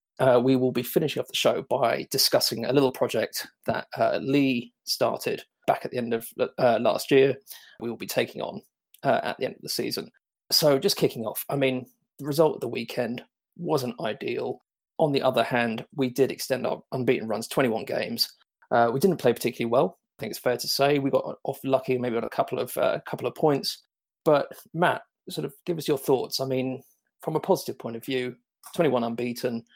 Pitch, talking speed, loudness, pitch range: 130 Hz, 210 wpm, -26 LUFS, 120-140 Hz